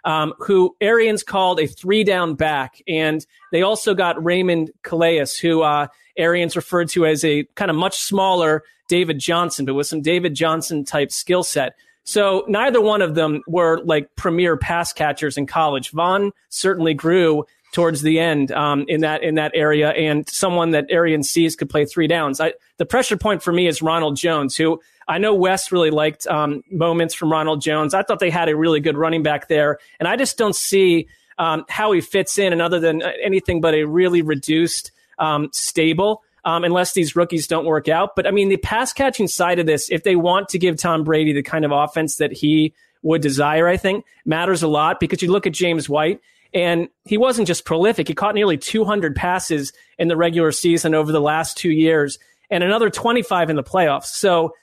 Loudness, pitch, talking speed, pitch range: -18 LUFS, 165 Hz, 205 wpm, 155-185 Hz